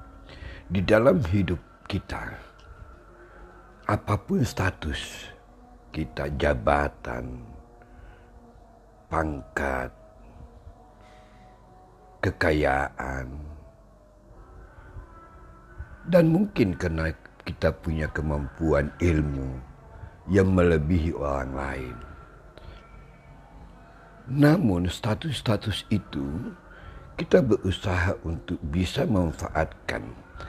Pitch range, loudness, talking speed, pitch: 70-95 Hz, -26 LUFS, 55 wpm, 85 Hz